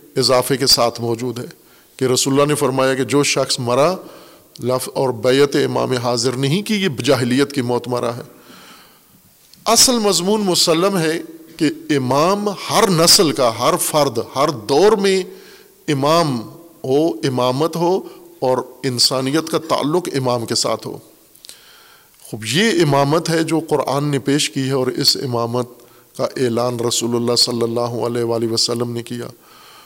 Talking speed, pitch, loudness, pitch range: 155 wpm, 135 Hz, -17 LUFS, 125-165 Hz